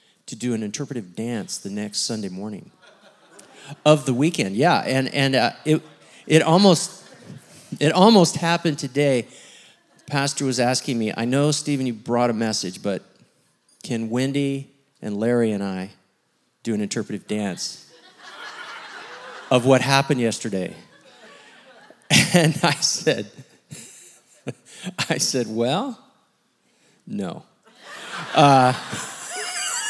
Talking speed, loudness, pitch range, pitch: 115 wpm, -21 LUFS, 115-150 Hz, 135 Hz